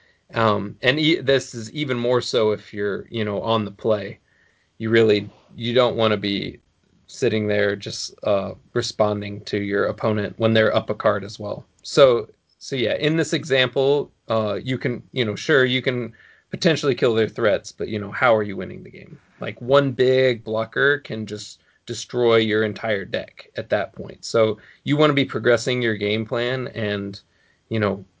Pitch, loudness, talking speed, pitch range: 110 Hz, -21 LUFS, 190 wpm, 105-125 Hz